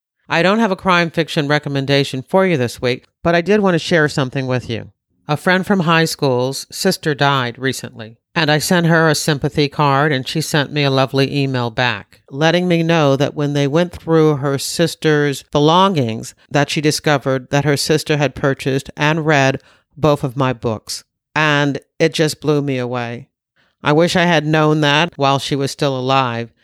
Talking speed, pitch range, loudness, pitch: 190 wpm, 135-160 Hz, -16 LUFS, 145 Hz